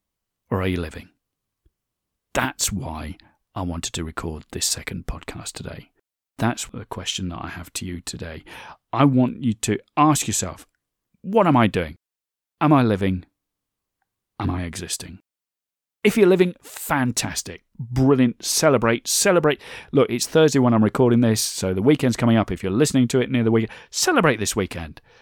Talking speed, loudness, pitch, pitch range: 165 wpm, -21 LUFS, 110 Hz, 90-130 Hz